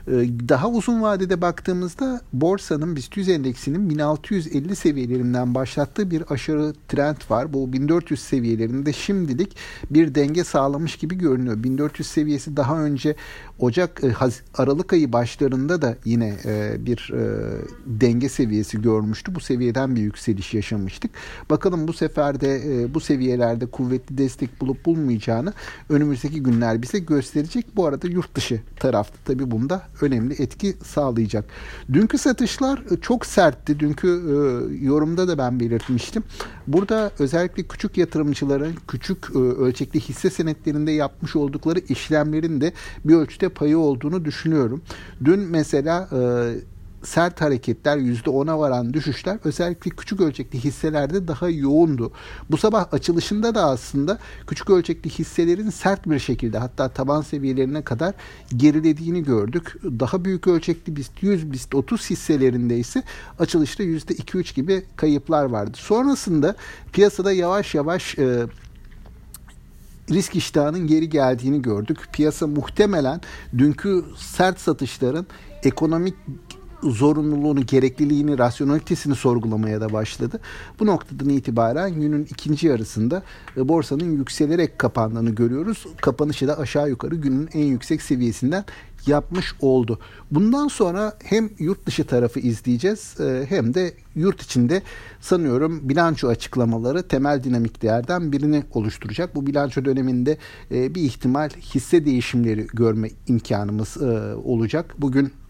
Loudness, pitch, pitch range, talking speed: -22 LUFS, 145 Hz, 125-170 Hz, 120 wpm